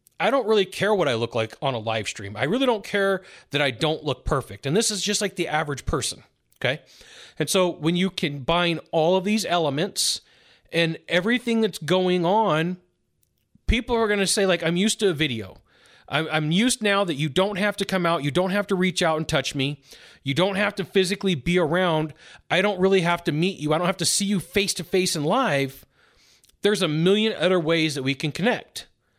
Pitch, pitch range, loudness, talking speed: 180 Hz, 155-200 Hz, -23 LUFS, 225 wpm